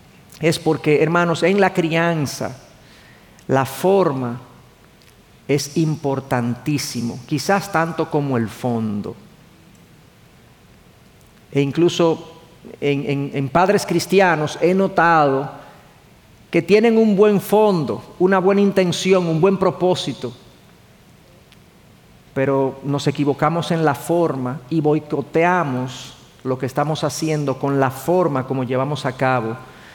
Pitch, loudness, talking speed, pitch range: 150 Hz, -19 LUFS, 110 wpm, 135-175 Hz